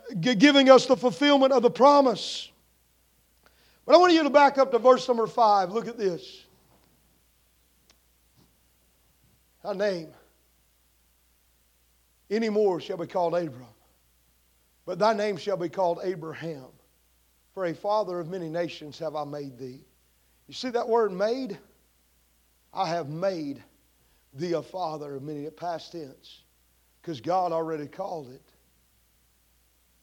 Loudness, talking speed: -24 LUFS, 130 wpm